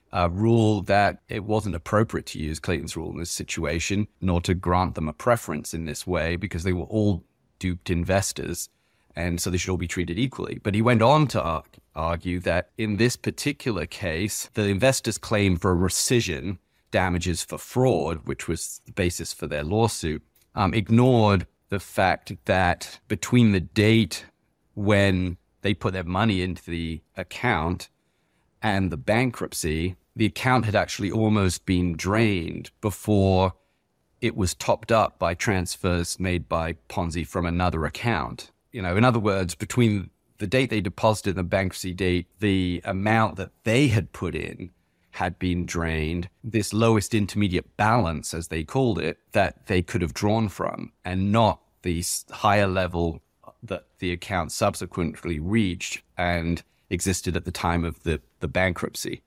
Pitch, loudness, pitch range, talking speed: 95 Hz, -25 LUFS, 85-110 Hz, 160 wpm